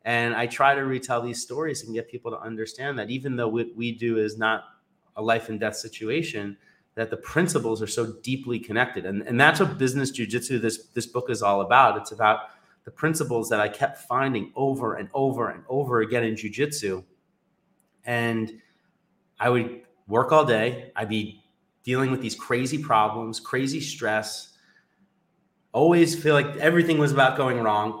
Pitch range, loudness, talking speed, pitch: 110-135 Hz, -24 LUFS, 180 wpm, 120 Hz